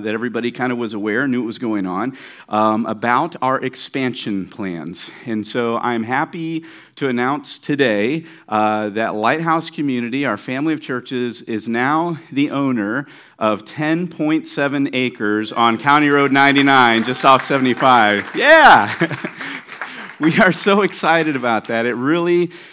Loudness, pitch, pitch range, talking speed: -17 LUFS, 130 Hz, 115-150 Hz, 145 wpm